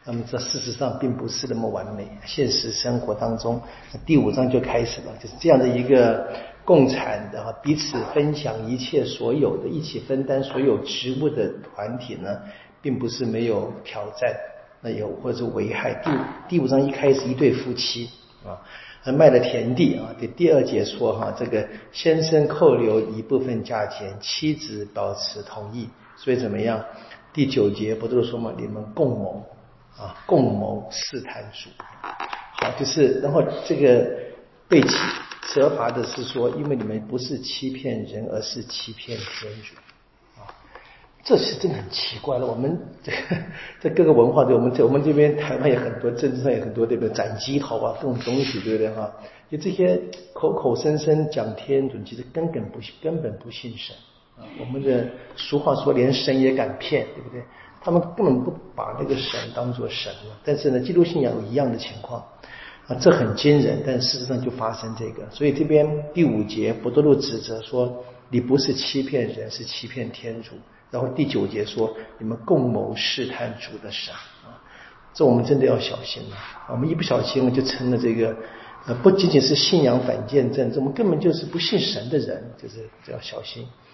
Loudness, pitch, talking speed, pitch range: -22 LUFS, 125 Hz, 270 characters per minute, 115-140 Hz